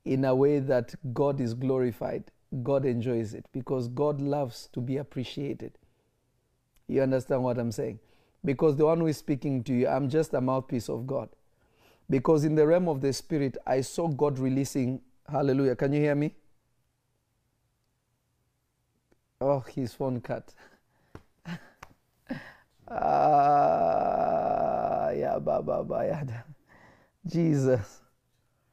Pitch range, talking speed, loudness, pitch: 125-150 Hz, 120 wpm, -28 LUFS, 135 Hz